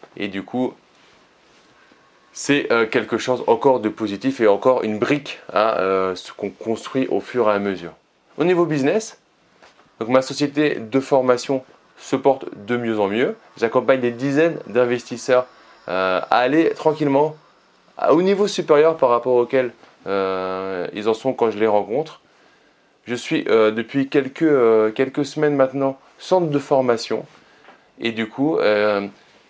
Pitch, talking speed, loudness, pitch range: 125 Hz, 155 wpm, -20 LUFS, 110-140 Hz